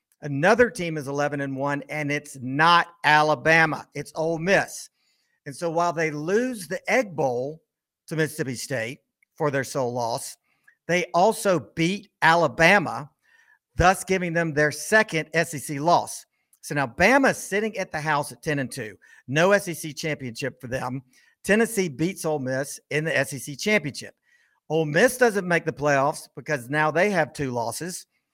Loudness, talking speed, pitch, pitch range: -23 LUFS, 160 wpm, 160 Hz, 145-185 Hz